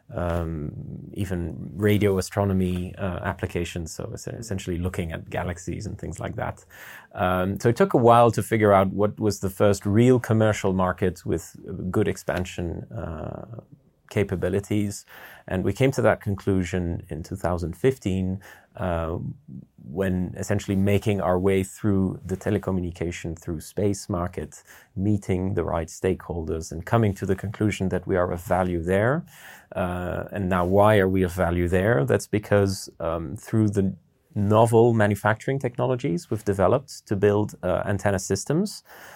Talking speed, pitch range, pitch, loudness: 145 wpm, 90-105 Hz, 95 Hz, -24 LUFS